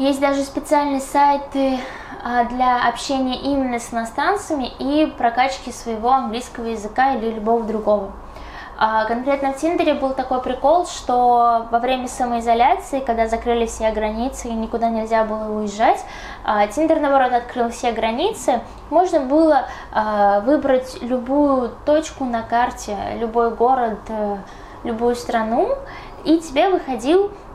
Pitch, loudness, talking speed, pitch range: 250 Hz, -19 LUFS, 120 wpm, 230-280 Hz